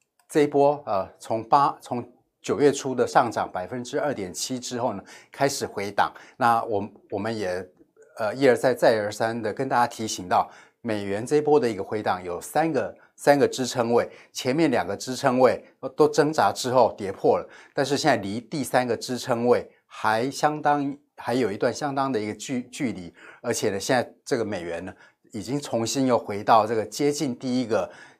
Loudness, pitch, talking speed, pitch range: -25 LUFS, 125 Hz, 275 characters per minute, 110-140 Hz